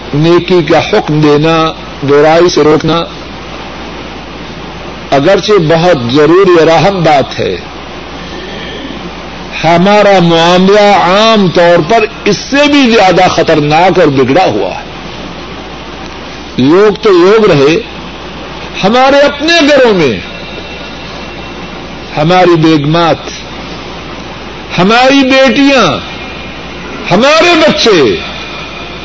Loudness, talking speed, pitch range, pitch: -6 LUFS, 85 wpm, 165-255 Hz, 180 Hz